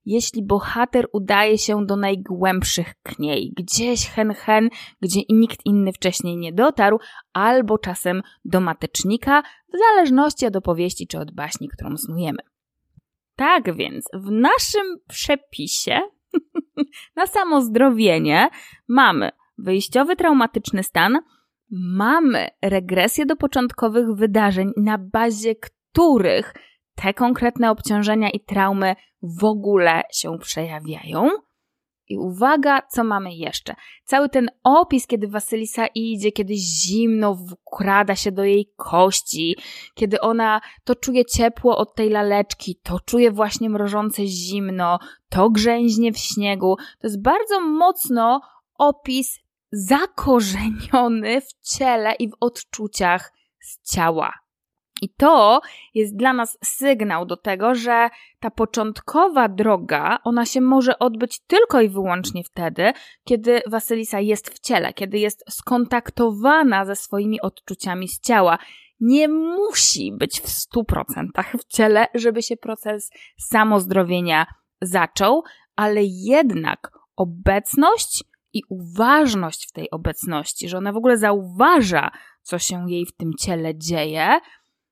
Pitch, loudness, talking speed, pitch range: 220 Hz, -19 LUFS, 120 wpm, 195-255 Hz